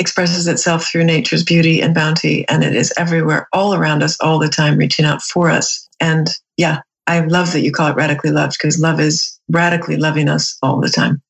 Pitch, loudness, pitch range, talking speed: 160 Hz, -14 LUFS, 155-170 Hz, 210 wpm